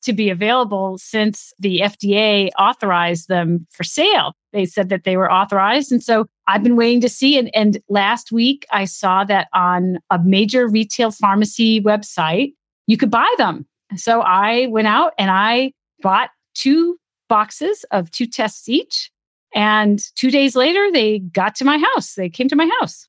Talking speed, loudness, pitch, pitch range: 175 wpm, -16 LUFS, 215 Hz, 195-245 Hz